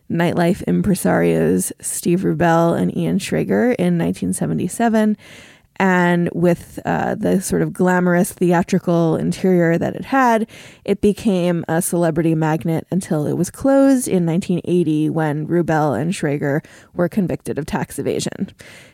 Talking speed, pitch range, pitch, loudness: 130 wpm, 160-190 Hz, 175 Hz, -18 LUFS